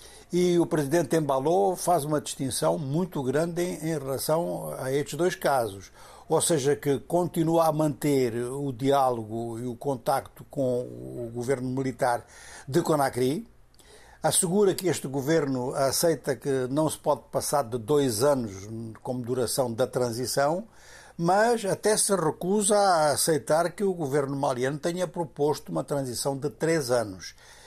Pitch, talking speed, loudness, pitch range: 145 Hz, 145 wpm, -26 LUFS, 130-165 Hz